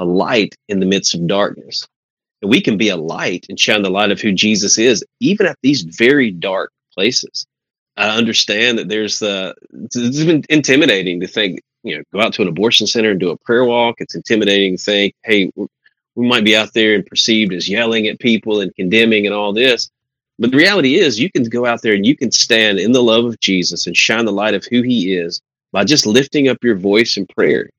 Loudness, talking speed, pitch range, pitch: -14 LUFS, 225 wpm, 100-115 Hz, 110 Hz